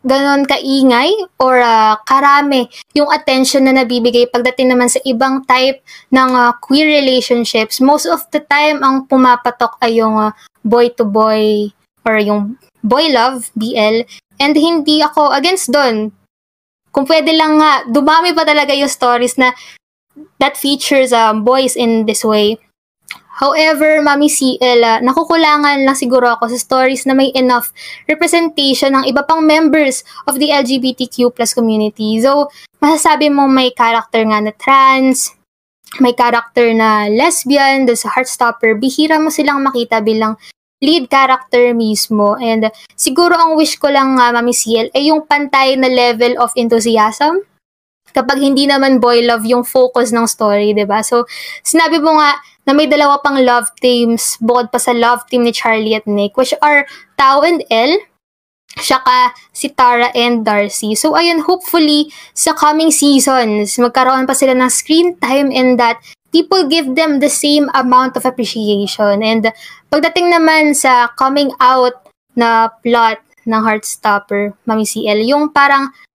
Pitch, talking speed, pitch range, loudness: 260 Hz, 155 wpm, 235-290 Hz, -11 LUFS